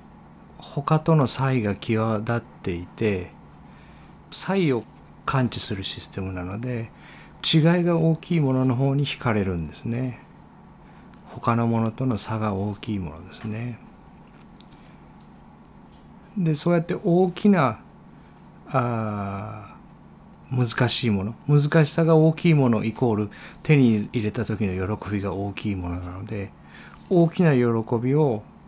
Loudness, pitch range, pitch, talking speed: -23 LUFS, 105-155 Hz, 120 Hz, 235 characters per minute